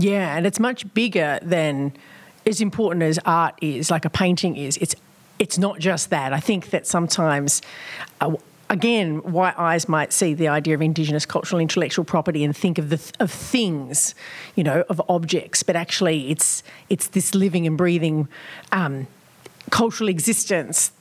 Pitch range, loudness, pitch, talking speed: 155-195 Hz, -21 LUFS, 175 Hz, 170 wpm